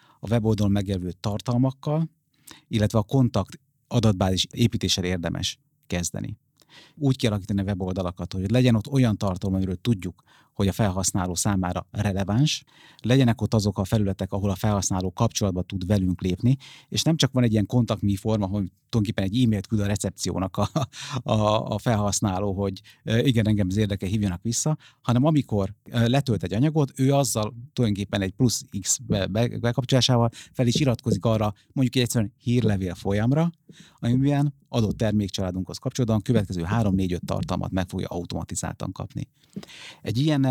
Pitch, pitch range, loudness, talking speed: 110 Hz, 100-125 Hz, -25 LUFS, 145 wpm